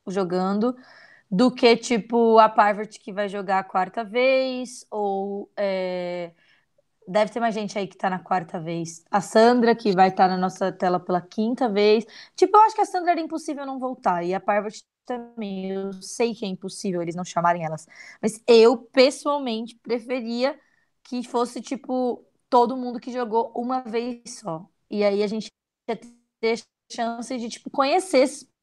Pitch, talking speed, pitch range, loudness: 230 Hz, 175 wpm, 195-250 Hz, -23 LUFS